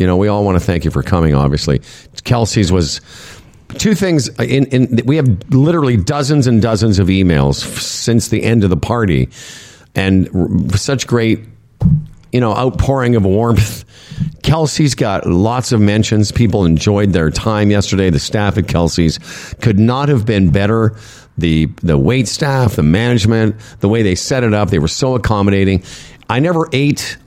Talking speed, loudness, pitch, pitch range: 170 wpm, -13 LUFS, 110 Hz, 95-125 Hz